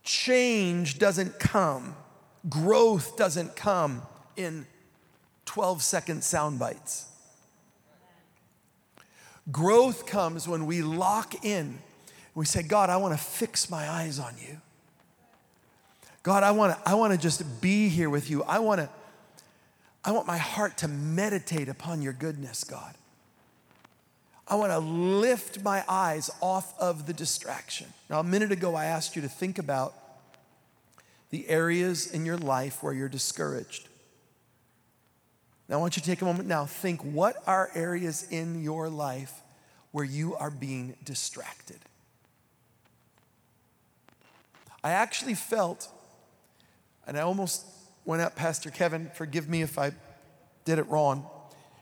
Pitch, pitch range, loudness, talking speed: 165 Hz, 150-190 Hz, -28 LUFS, 140 wpm